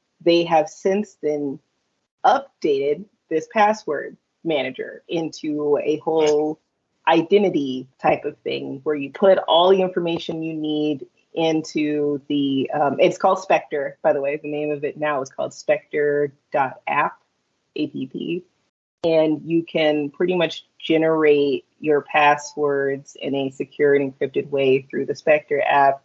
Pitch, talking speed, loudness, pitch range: 155 Hz, 135 wpm, -21 LUFS, 145-170 Hz